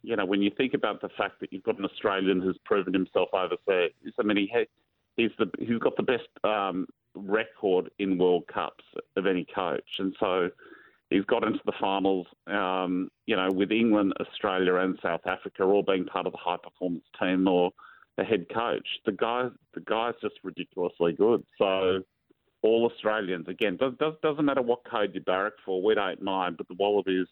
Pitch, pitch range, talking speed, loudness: 95 Hz, 95-110 Hz, 195 wpm, -28 LUFS